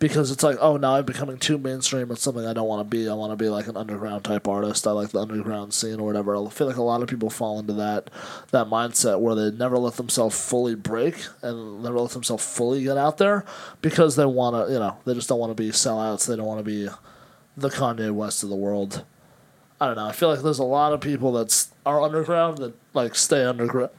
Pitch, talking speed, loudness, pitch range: 120 Hz, 255 wpm, -23 LUFS, 110-135 Hz